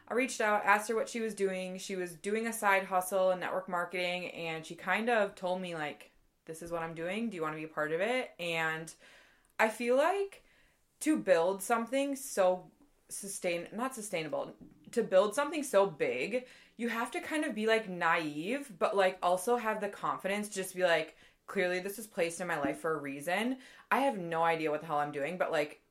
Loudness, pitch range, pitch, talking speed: -33 LUFS, 170-235 Hz, 195 Hz, 220 wpm